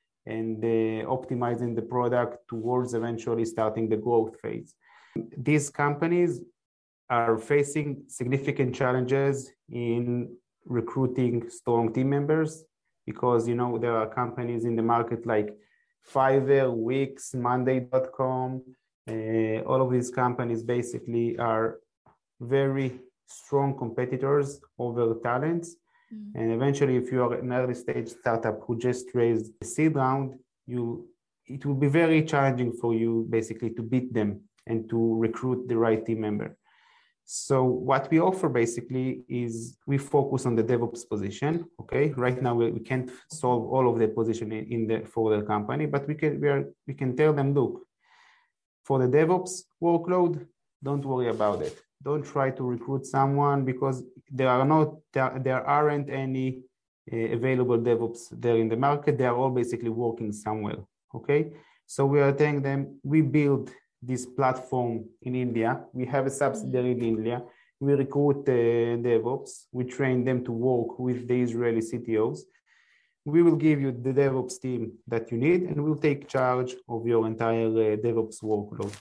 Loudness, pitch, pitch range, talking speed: -27 LUFS, 125 Hz, 115-140 Hz, 155 wpm